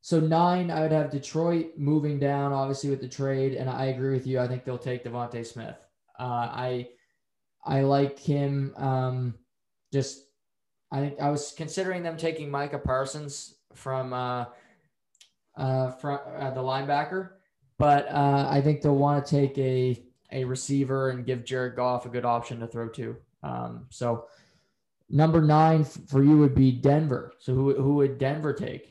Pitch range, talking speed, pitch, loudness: 125-145 Hz, 170 wpm, 135 Hz, -27 LUFS